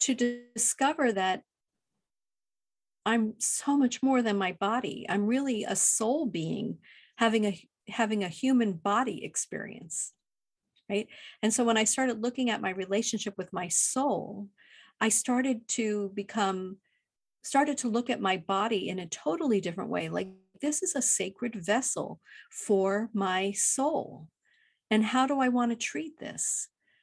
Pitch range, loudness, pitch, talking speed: 200-255 Hz, -29 LUFS, 225 Hz, 150 wpm